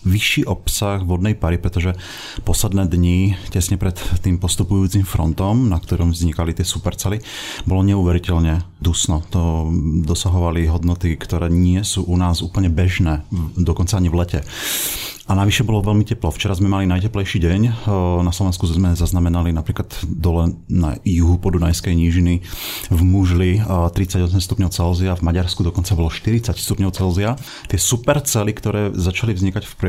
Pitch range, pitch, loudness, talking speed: 85-100 Hz, 90 Hz, -18 LUFS, 145 wpm